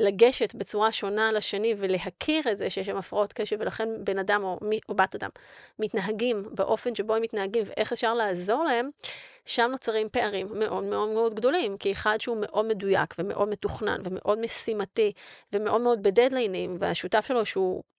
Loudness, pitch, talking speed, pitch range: -27 LUFS, 215 Hz, 165 wpm, 200-230 Hz